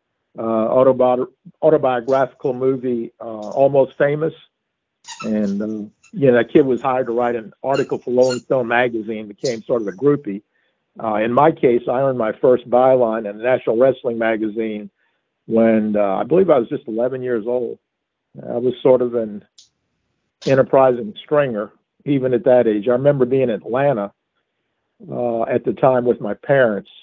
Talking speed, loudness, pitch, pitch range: 165 wpm, -18 LUFS, 125 Hz, 115-135 Hz